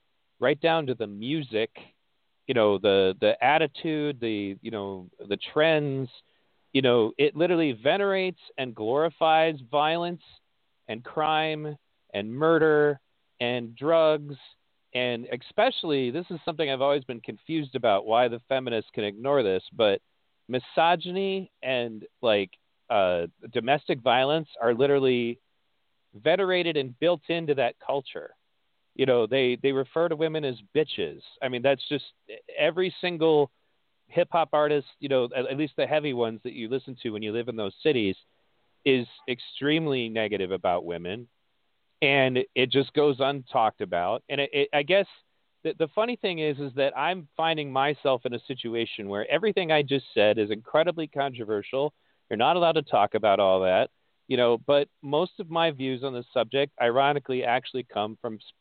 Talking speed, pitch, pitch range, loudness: 160 wpm, 140 Hz, 120-155 Hz, -26 LUFS